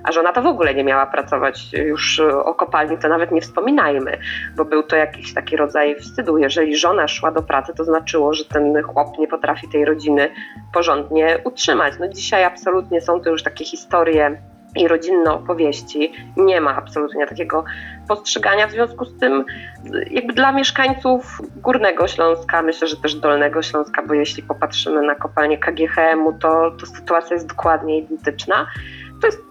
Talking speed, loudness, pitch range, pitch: 165 wpm, -18 LUFS, 150-170 Hz, 160 Hz